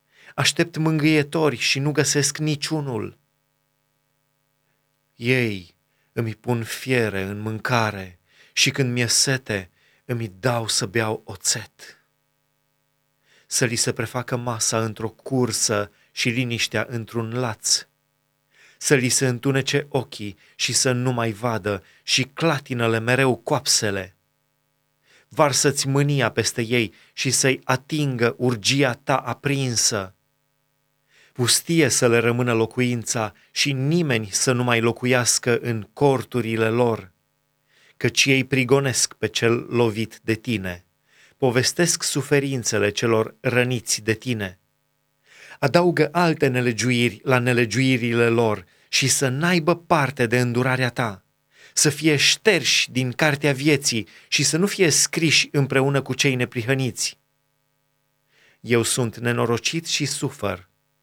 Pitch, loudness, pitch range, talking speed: 125 Hz, -21 LUFS, 115-140 Hz, 115 wpm